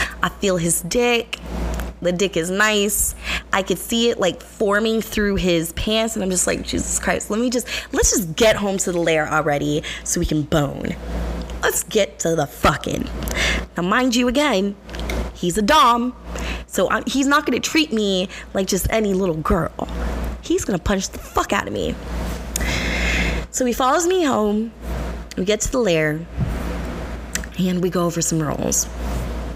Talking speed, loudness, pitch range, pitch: 175 wpm, -20 LUFS, 155-225 Hz, 190 Hz